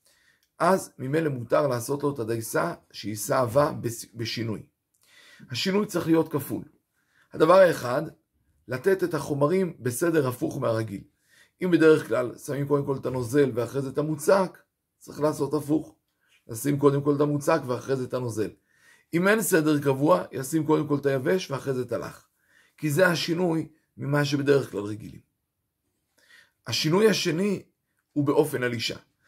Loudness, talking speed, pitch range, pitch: -25 LUFS, 145 wpm, 125-160 Hz, 145 Hz